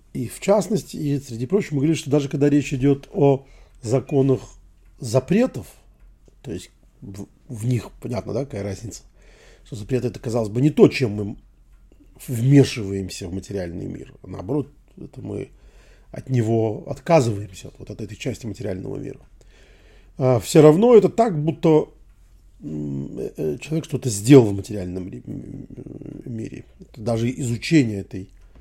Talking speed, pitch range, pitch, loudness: 140 wpm, 105-145 Hz, 125 Hz, -21 LUFS